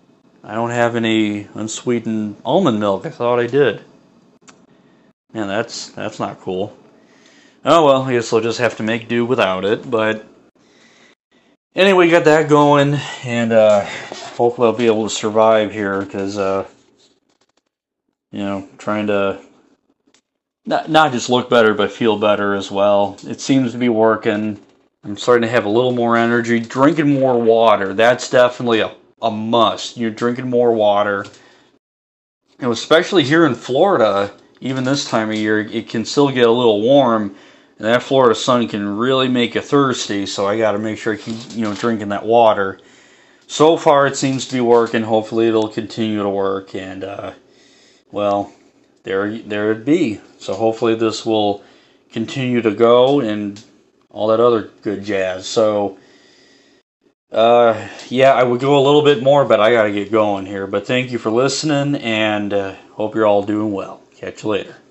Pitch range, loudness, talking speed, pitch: 105-120 Hz, -16 LUFS, 175 wpm, 110 Hz